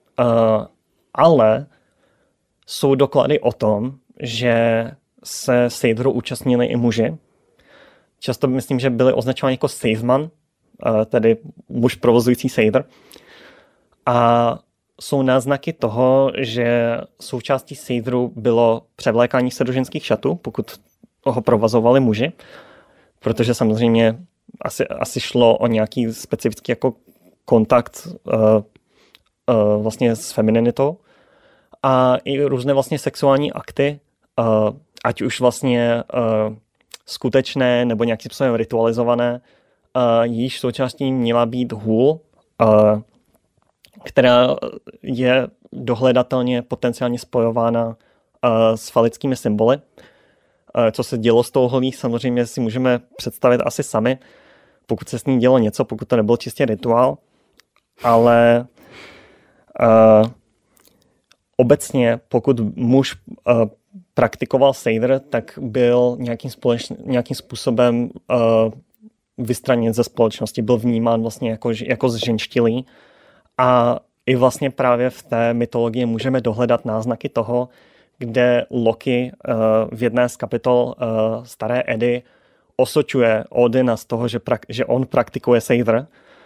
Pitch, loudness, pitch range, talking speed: 120 Hz, -18 LUFS, 115-130 Hz, 115 wpm